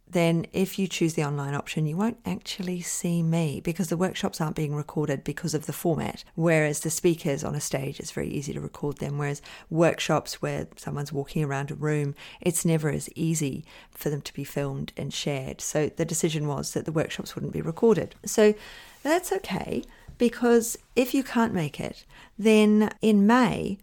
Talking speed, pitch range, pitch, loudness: 190 wpm, 150-205 Hz, 165 Hz, -27 LUFS